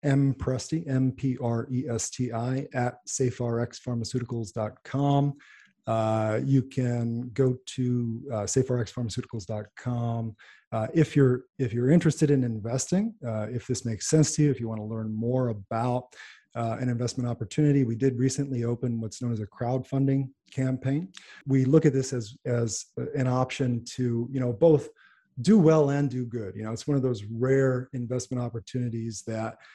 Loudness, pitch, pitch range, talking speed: -27 LUFS, 125 Hz, 115-135 Hz, 160 wpm